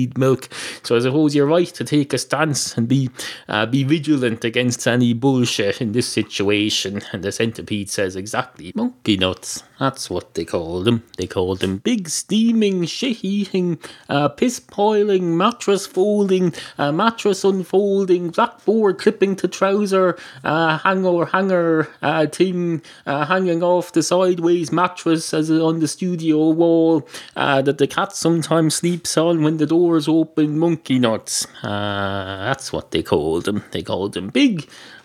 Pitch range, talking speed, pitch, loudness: 130-185 Hz, 150 wpm, 160 Hz, -19 LUFS